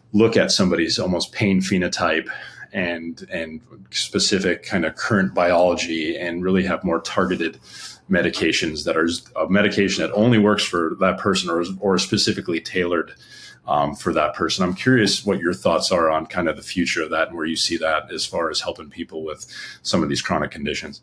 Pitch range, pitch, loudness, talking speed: 85-105 Hz, 90 Hz, -20 LUFS, 190 wpm